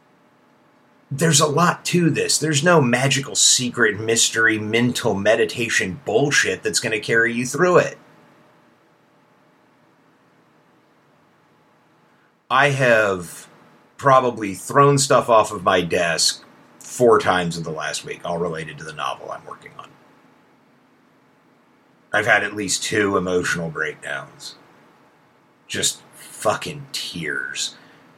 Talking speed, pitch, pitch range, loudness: 115 wpm, 125 Hz, 115-150 Hz, -19 LUFS